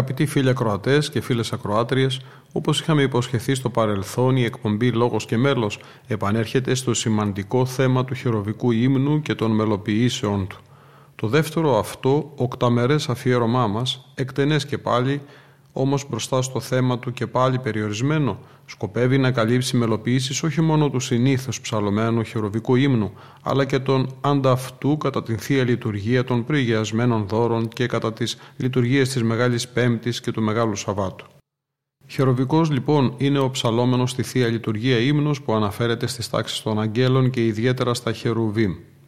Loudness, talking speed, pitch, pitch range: -21 LUFS, 145 wpm, 125 Hz, 115-135 Hz